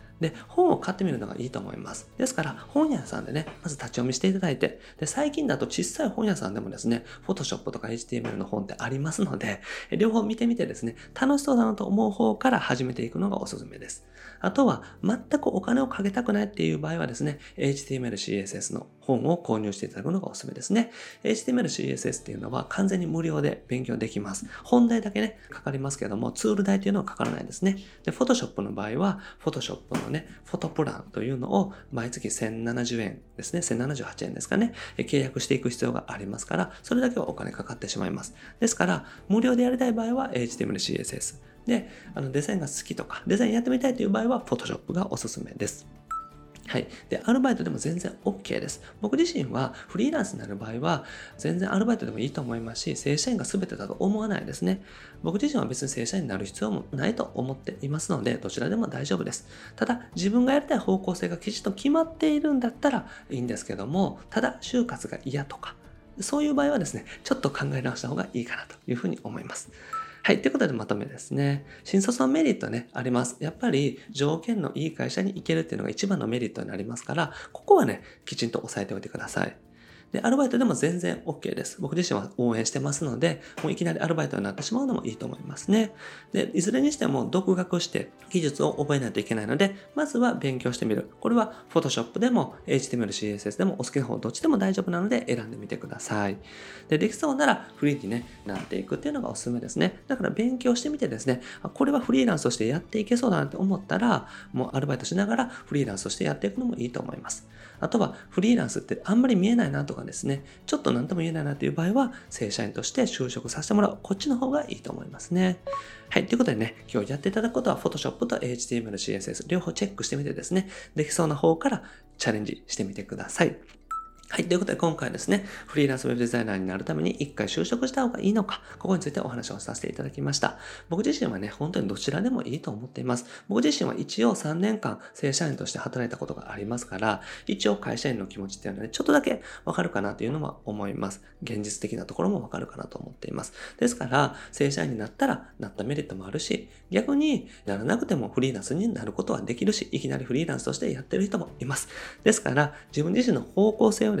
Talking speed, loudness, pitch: 490 characters per minute, -28 LUFS, 185 Hz